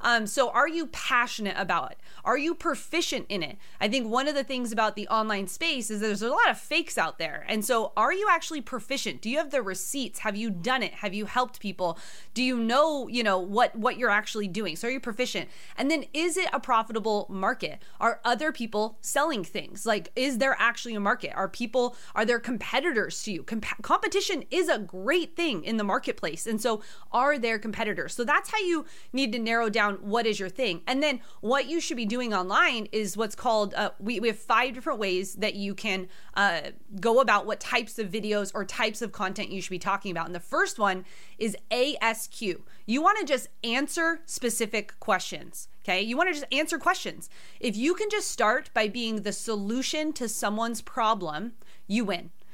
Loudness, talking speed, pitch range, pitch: -28 LUFS, 210 wpm, 205-265 Hz, 230 Hz